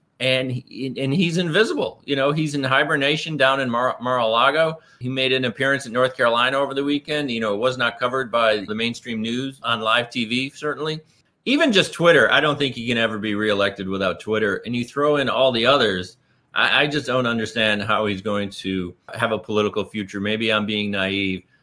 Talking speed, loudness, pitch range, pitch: 210 wpm, -20 LUFS, 110-140 Hz, 125 Hz